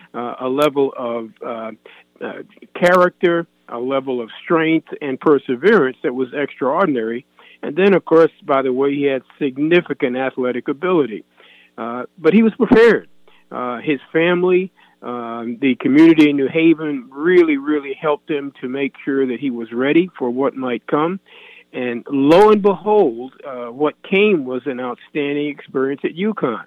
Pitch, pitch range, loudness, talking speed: 145 Hz, 125-175 Hz, -17 LUFS, 160 wpm